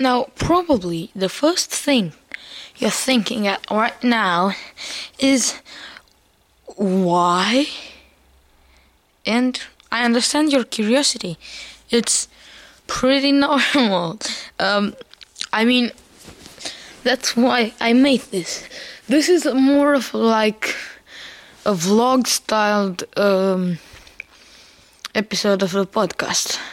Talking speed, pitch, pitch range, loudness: 90 wpm, 230 Hz, 200-270 Hz, -19 LUFS